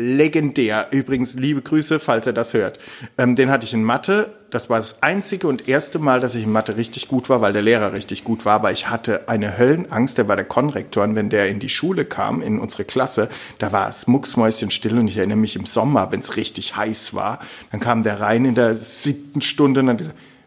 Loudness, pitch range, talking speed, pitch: -19 LUFS, 110-135 Hz, 230 wpm, 120 Hz